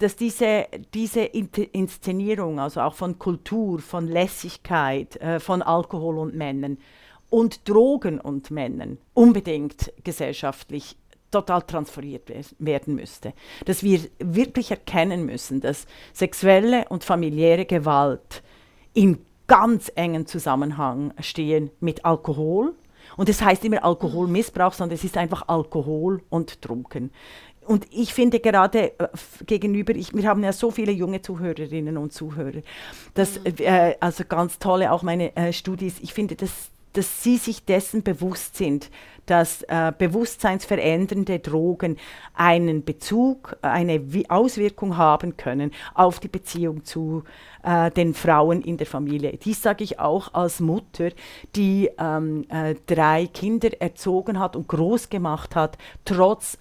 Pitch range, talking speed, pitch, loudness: 155-200 Hz, 140 wpm, 175 Hz, -22 LUFS